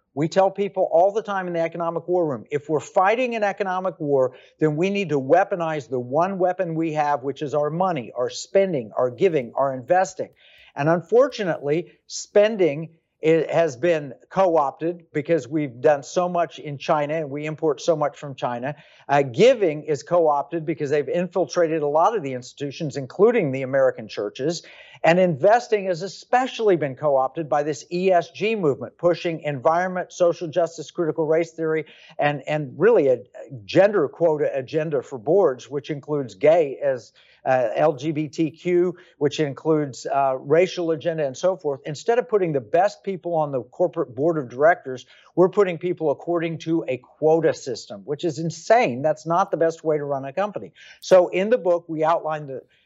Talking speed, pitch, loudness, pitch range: 175 wpm, 160 Hz, -22 LUFS, 145-180 Hz